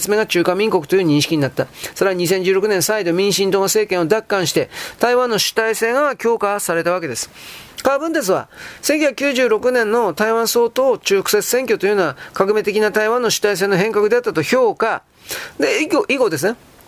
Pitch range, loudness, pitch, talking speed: 195-280 Hz, -17 LUFS, 215 Hz, 325 characters per minute